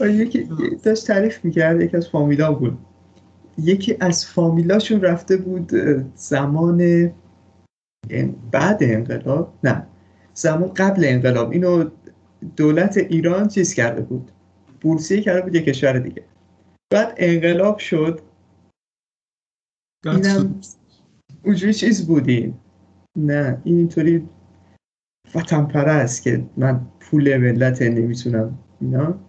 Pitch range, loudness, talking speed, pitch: 125-180 Hz, -18 LUFS, 105 wpm, 160 Hz